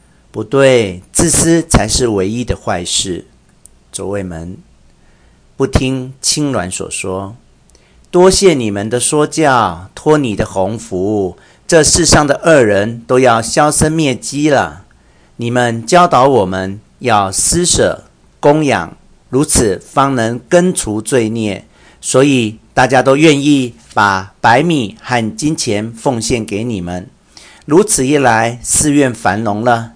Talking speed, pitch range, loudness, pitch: 180 characters per minute, 100-140 Hz, -12 LUFS, 120 Hz